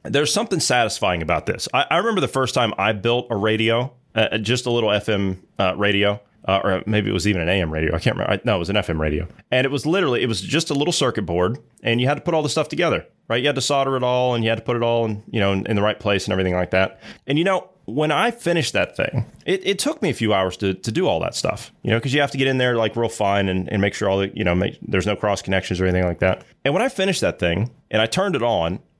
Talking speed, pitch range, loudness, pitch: 305 wpm, 95-135 Hz, -21 LUFS, 110 Hz